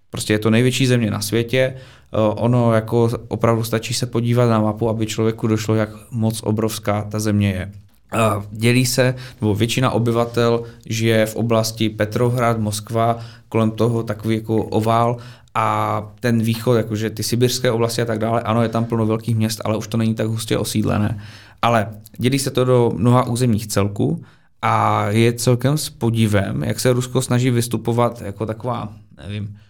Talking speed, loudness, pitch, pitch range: 170 wpm, -19 LUFS, 115 Hz, 110-120 Hz